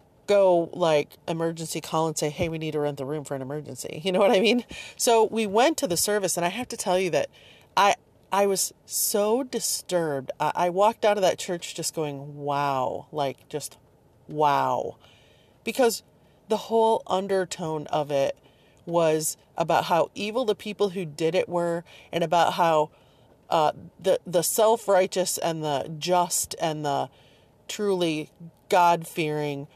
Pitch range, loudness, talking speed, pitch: 150-195 Hz, -25 LUFS, 165 wpm, 165 Hz